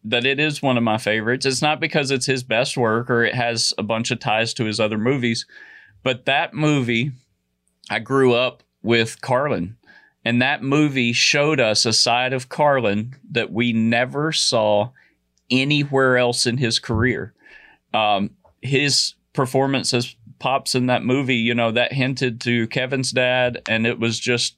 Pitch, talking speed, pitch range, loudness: 125 Hz, 170 wpm, 115-135 Hz, -19 LUFS